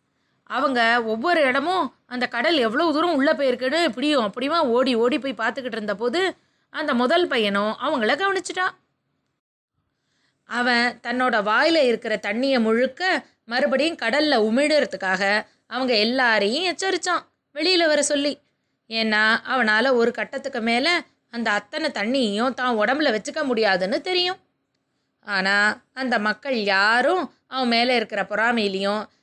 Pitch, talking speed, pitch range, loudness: 250 Hz, 120 wpm, 225-295 Hz, -21 LUFS